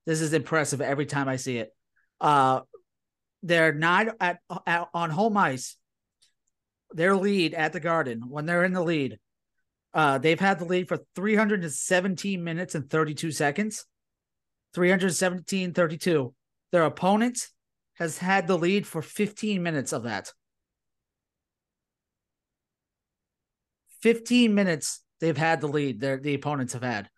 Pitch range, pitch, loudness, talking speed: 150-190 Hz, 170 Hz, -26 LUFS, 135 wpm